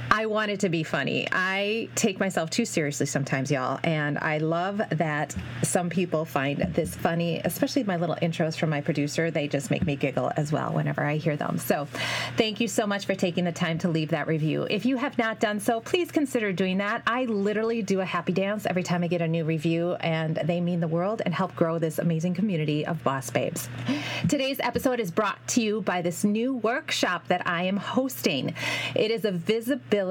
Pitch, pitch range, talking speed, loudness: 175 Hz, 160-215 Hz, 215 wpm, -26 LUFS